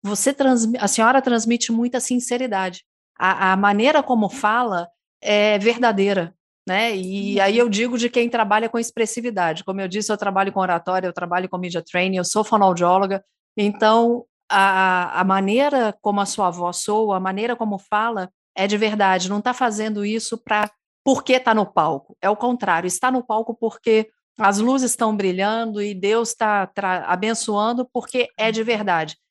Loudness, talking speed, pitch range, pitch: -20 LUFS, 170 wpm, 190-235 Hz, 210 Hz